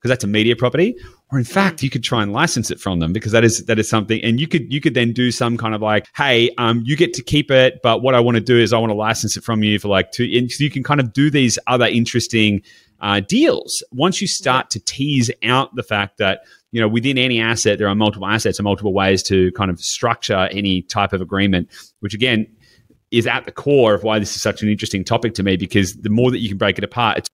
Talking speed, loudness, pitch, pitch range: 270 wpm, -17 LUFS, 115 Hz, 105-125 Hz